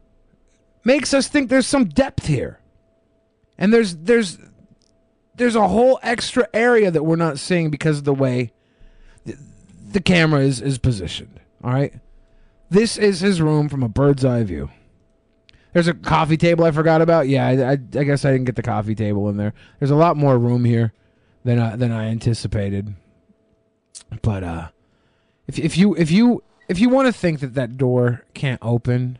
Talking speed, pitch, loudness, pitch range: 180 wpm, 140 Hz, -18 LUFS, 115-185 Hz